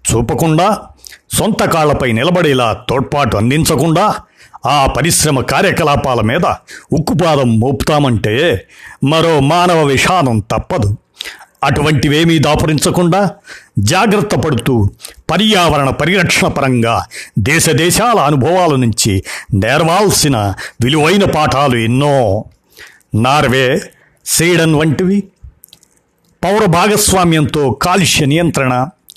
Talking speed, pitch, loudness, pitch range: 75 wpm, 150 Hz, -12 LUFS, 125-170 Hz